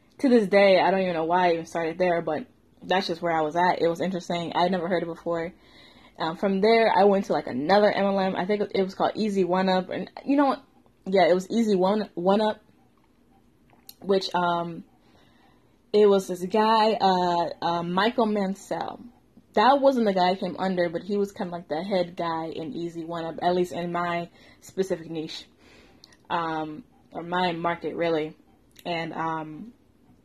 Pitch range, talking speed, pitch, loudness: 170-200 Hz, 195 wpm, 180 Hz, -25 LUFS